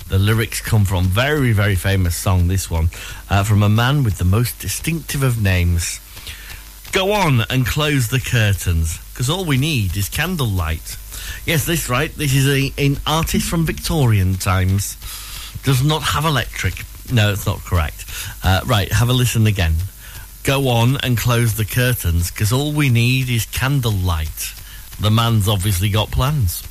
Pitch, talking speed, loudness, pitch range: 105 Hz, 165 wpm, -18 LUFS, 95-130 Hz